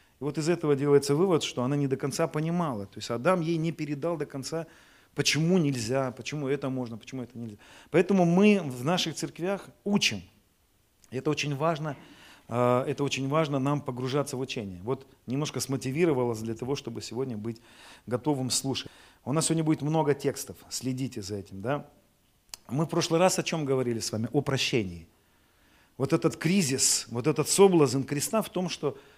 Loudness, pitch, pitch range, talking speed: -28 LUFS, 140 Hz, 120-160 Hz, 175 wpm